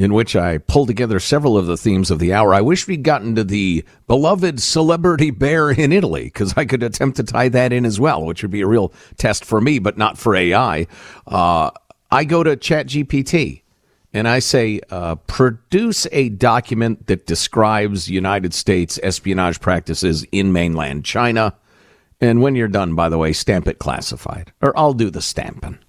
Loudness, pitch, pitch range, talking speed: -17 LUFS, 110 Hz, 95-135 Hz, 190 wpm